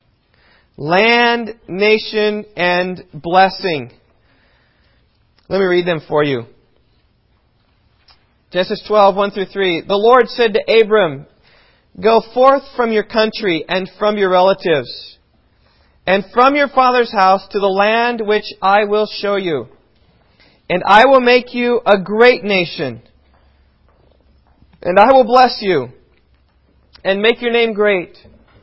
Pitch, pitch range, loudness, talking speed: 200 Hz, 170-225 Hz, -14 LUFS, 125 wpm